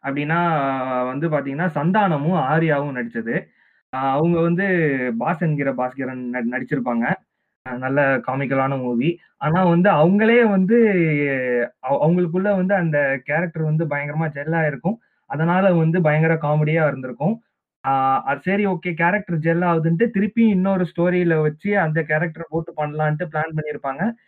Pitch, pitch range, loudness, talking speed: 160 Hz, 140-180 Hz, -20 LUFS, 115 wpm